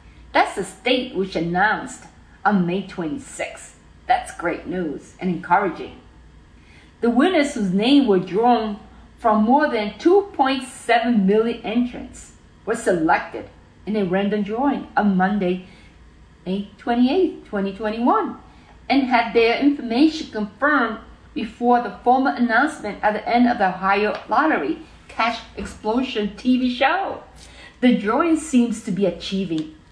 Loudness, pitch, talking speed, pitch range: -20 LUFS, 225 Hz, 125 wpm, 195-260 Hz